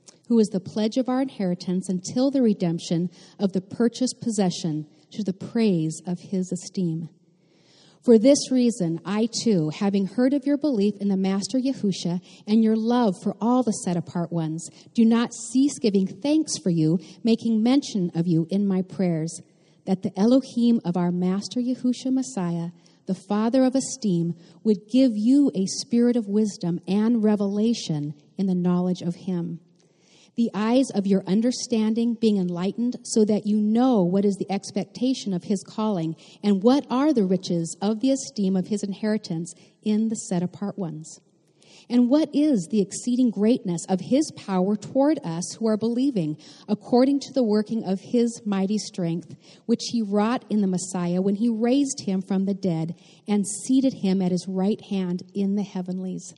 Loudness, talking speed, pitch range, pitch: -24 LUFS, 170 wpm, 180-235 Hz, 200 Hz